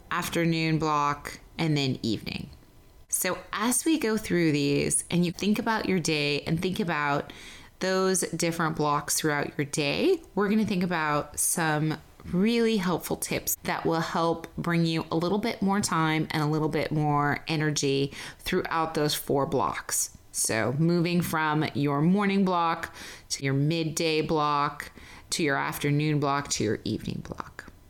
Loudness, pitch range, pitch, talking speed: -27 LUFS, 145-175 Hz, 160 Hz, 155 wpm